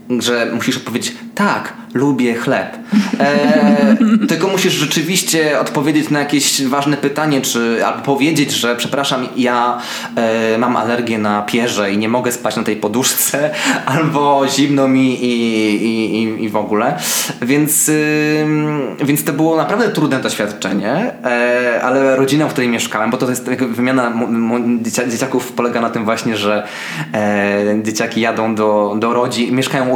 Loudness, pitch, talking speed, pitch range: -15 LUFS, 125 Hz, 150 wpm, 115-145 Hz